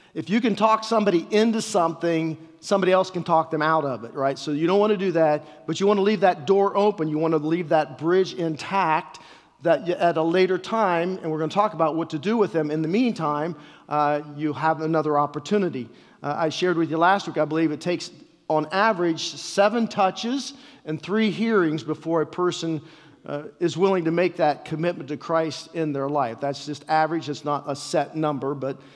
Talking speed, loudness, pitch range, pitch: 215 wpm, -23 LUFS, 155-185 Hz, 160 Hz